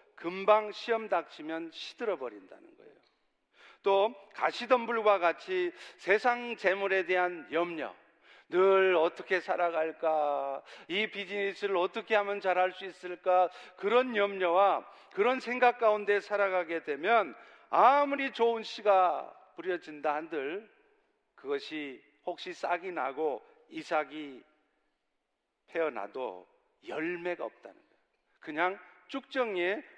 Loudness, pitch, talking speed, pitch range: -30 LUFS, 195 Hz, 240 characters per minute, 175-235 Hz